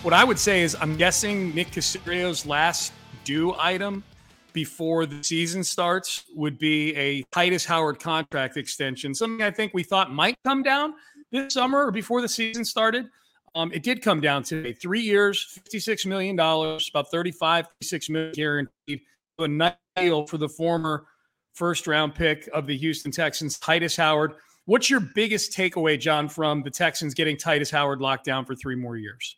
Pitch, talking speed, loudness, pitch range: 165 Hz, 170 wpm, -24 LUFS, 150-195 Hz